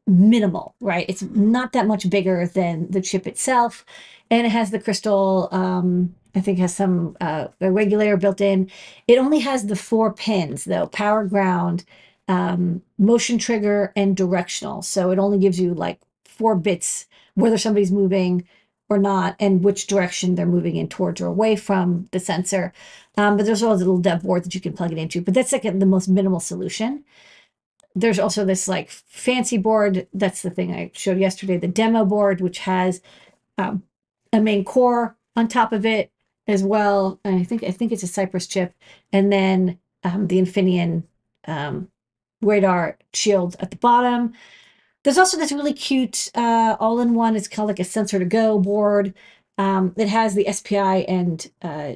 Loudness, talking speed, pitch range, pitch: -20 LUFS, 180 wpm, 185-220 Hz, 195 Hz